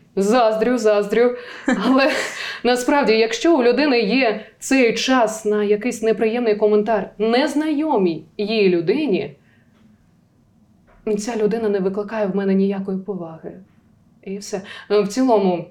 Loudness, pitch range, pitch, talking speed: -18 LUFS, 205-245 Hz, 220 Hz, 110 wpm